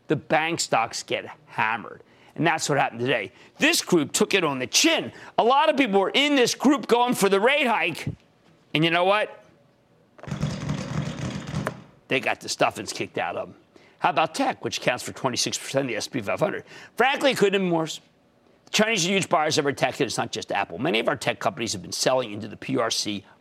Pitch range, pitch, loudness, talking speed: 155-255 Hz, 195 Hz, -23 LUFS, 215 wpm